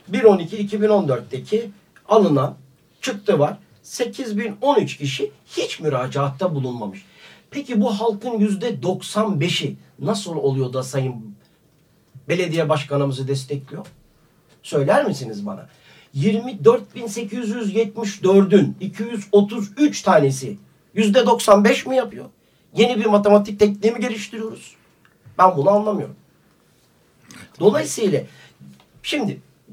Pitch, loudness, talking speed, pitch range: 200 Hz, -20 LUFS, 85 wpm, 145-220 Hz